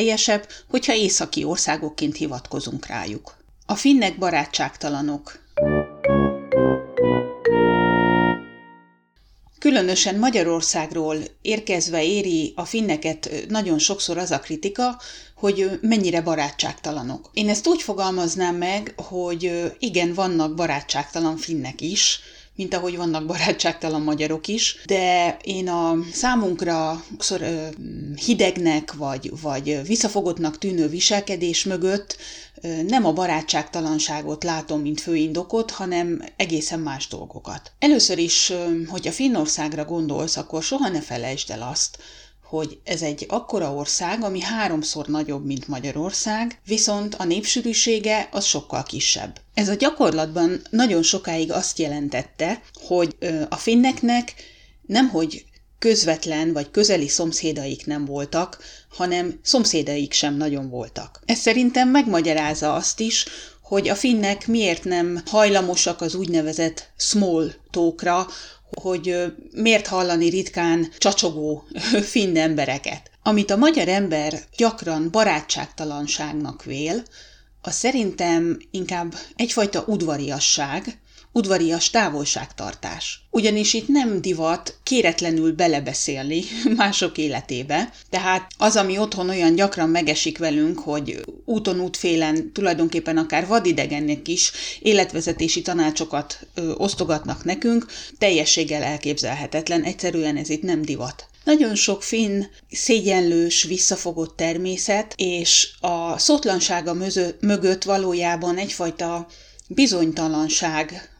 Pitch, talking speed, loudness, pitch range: 175 Hz, 105 wpm, -21 LUFS, 155-200 Hz